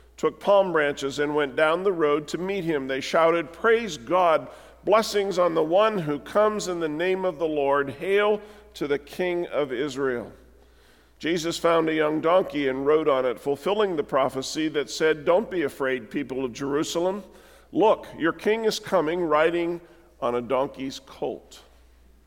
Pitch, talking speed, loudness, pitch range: 160 Hz, 170 wpm, -24 LUFS, 140-185 Hz